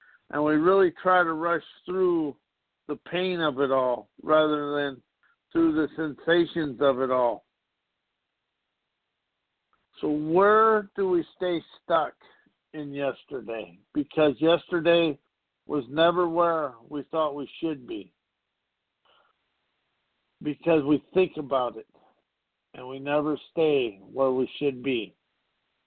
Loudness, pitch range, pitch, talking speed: -26 LUFS, 140-170 Hz, 155 Hz, 120 wpm